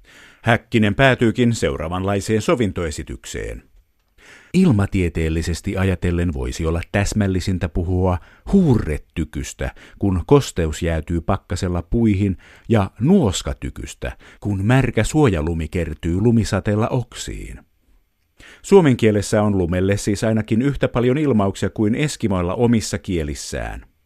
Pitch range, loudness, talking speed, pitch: 85-115 Hz, -19 LUFS, 90 wpm, 100 Hz